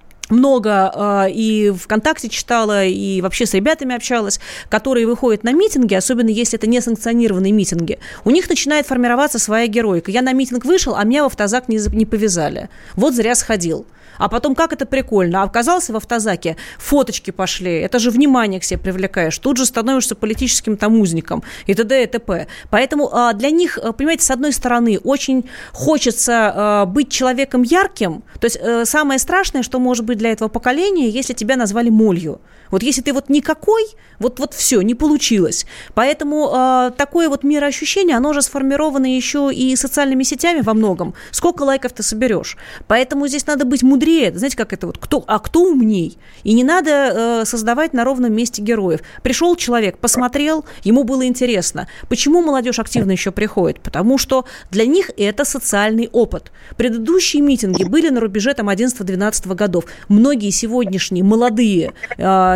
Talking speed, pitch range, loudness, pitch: 160 wpm, 215-275 Hz, -16 LUFS, 240 Hz